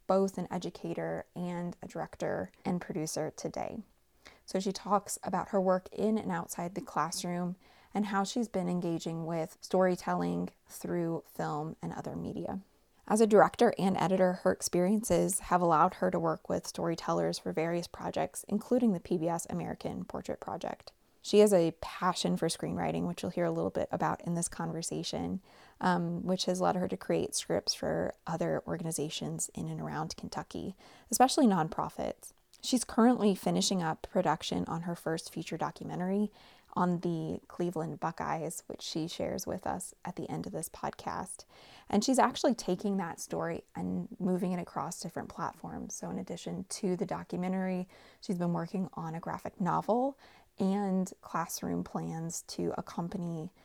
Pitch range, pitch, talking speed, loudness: 160-195 Hz, 180 Hz, 160 wpm, -33 LUFS